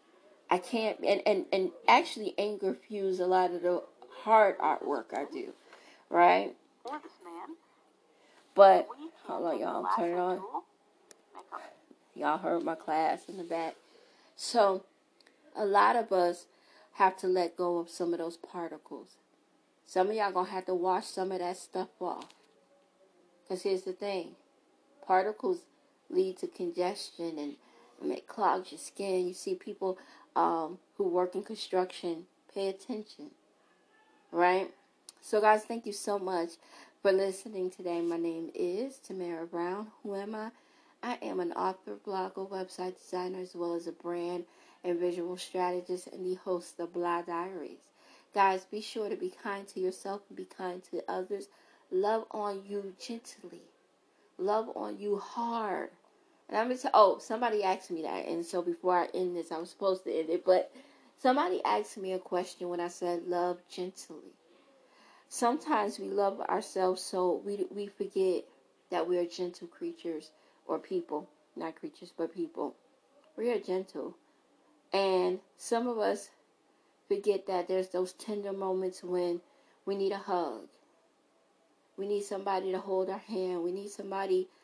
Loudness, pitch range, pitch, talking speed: -32 LUFS, 180-210 Hz, 190 Hz, 155 wpm